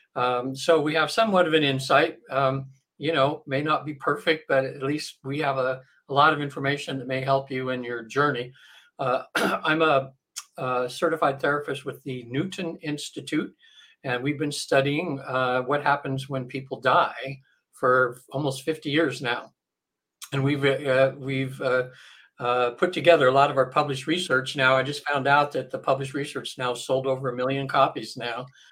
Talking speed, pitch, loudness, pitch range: 180 wpm, 135 Hz, -25 LUFS, 130-145 Hz